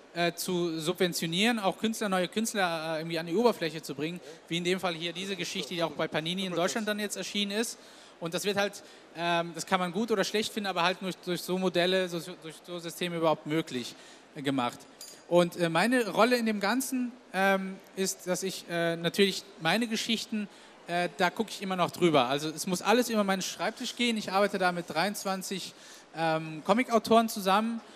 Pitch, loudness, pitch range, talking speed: 185 Hz, -29 LUFS, 170-210 Hz, 180 wpm